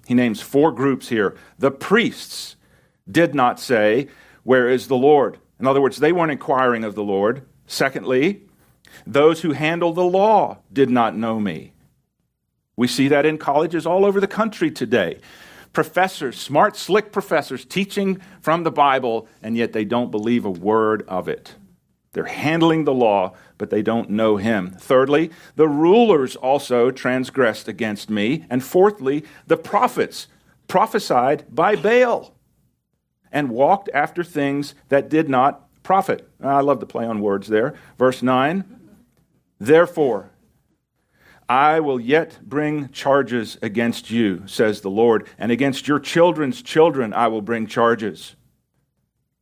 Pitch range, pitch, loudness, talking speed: 115-160 Hz, 135 Hz, -19 LUFS, 145 wpm